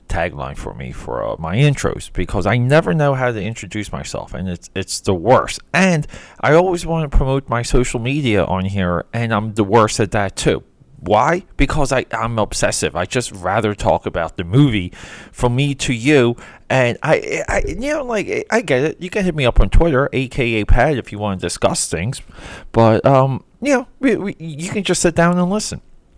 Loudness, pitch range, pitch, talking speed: -17 LUFS, 100-155 Hz, 125 Hz, 210 wpm